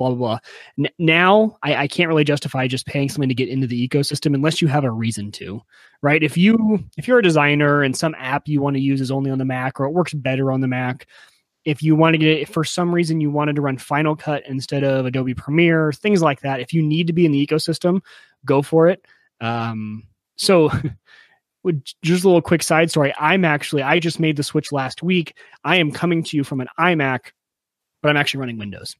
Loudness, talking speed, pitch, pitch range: -19 LUFS, 230 wpm, 145 Hz, 135-165 Hz